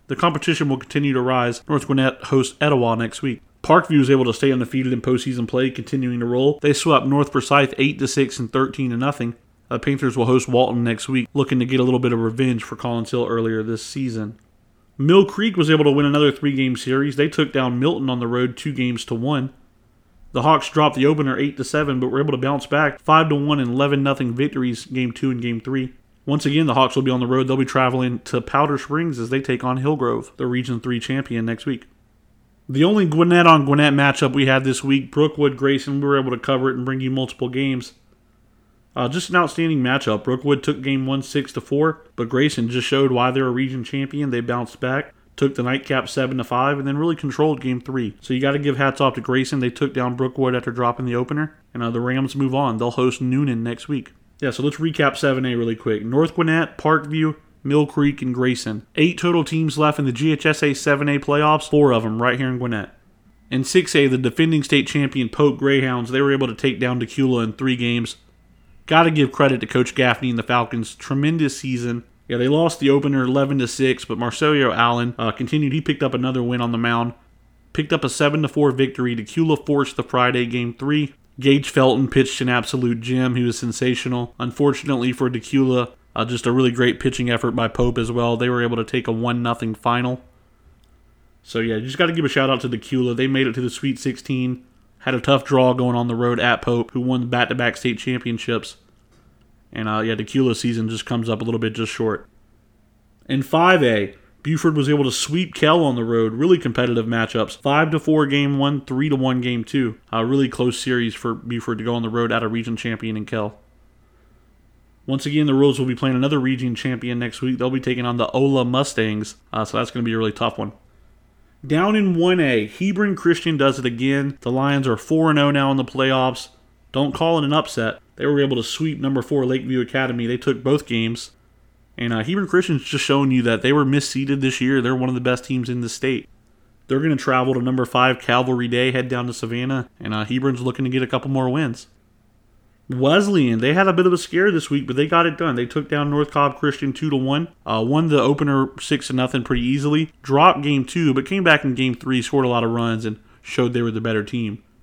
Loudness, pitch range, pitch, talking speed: -20 LUFS, 120-140 Hz, 130 Hz, 230 wpm